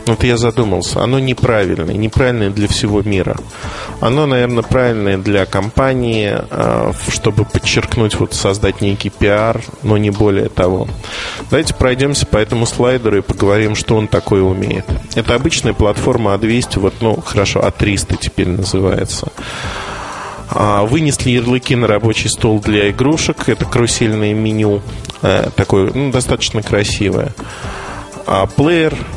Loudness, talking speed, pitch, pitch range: -14 LUFS, 125 wpm, 110 Hz, 100-125 Hz